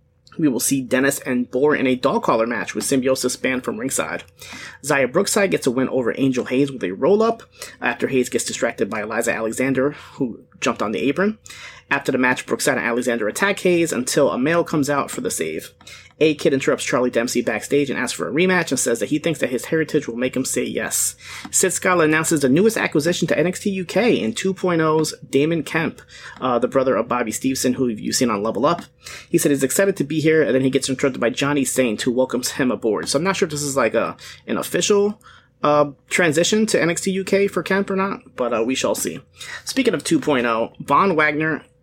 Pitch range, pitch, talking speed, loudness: 130-175 Hz, 145 Hz, 220 wpm, -20 LUFS